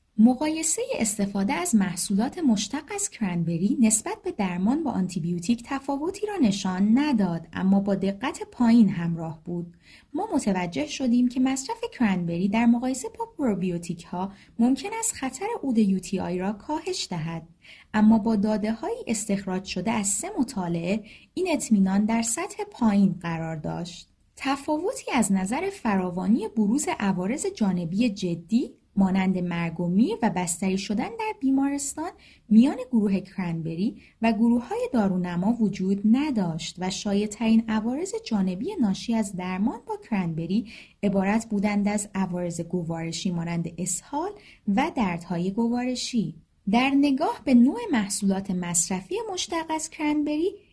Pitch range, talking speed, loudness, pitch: 190-270 Hz, 135 wpm, -25 LUFS, 220 Hz